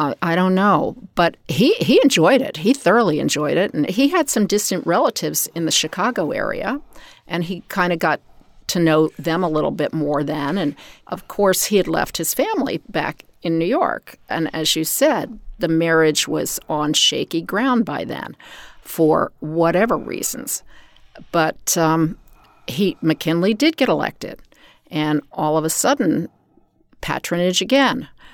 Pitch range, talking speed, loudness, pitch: 160-205 Hz, 165 wpm, -19 LUFS, 170 Hz